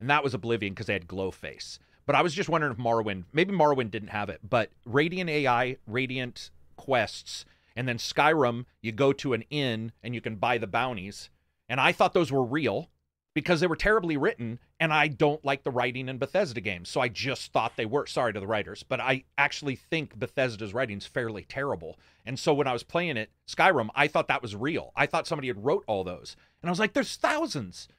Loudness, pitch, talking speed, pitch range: -28 LUFS, 125 Hz, 225 wpm, 105-150 Hz